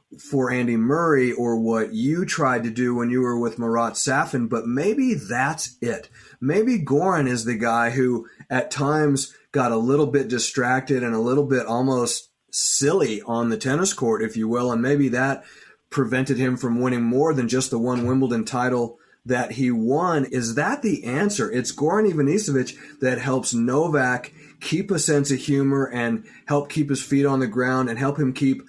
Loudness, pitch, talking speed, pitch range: -22 LUFS, 130 Hz, 185 wpm, 120-140 Hz